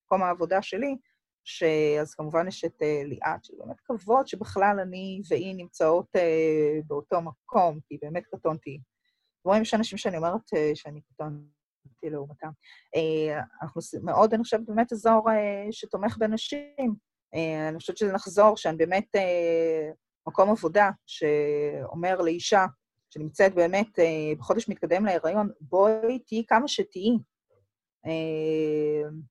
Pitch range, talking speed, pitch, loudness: 155-205 Hz, 135 wpm, 170 Hz, -26 LUFS